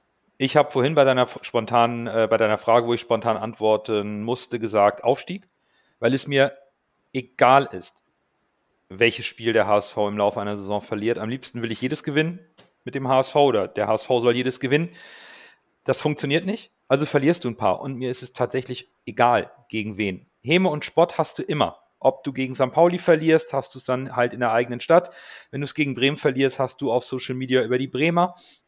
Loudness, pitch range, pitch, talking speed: -22 LUFS, 115-145 Hz, 130 Hz, 205 wpm